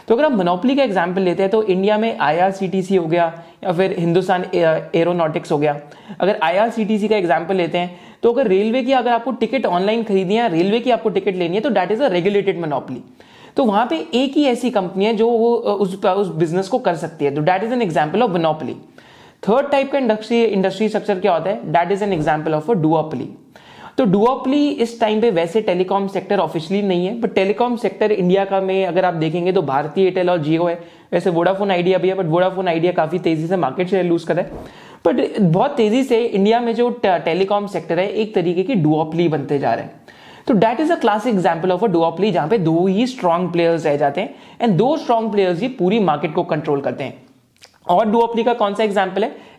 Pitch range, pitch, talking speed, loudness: 175-225 Hz, 190 Hz, 215 wpm, -18 LUFS